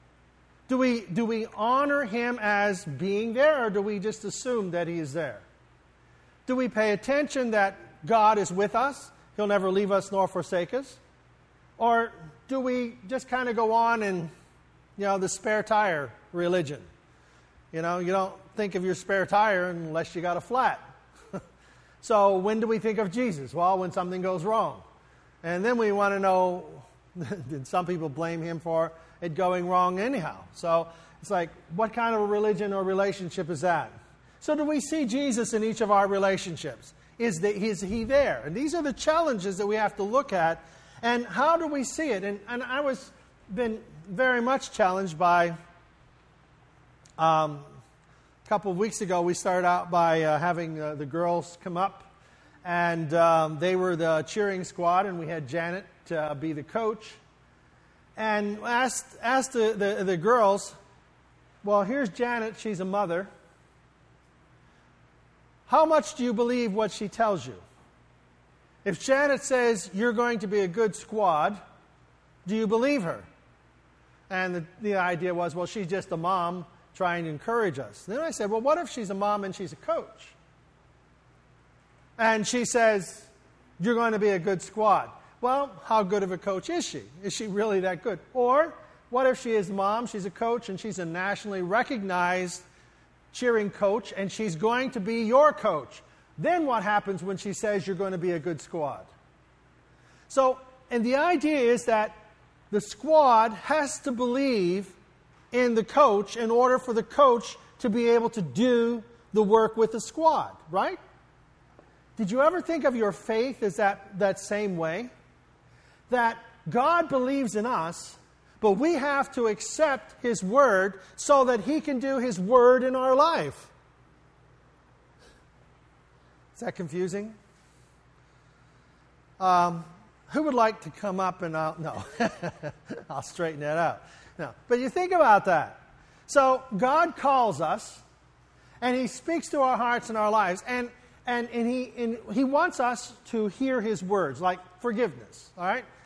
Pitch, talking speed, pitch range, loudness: 205 Hz, 170 wpm, 180-240 Hz, -27 LUFS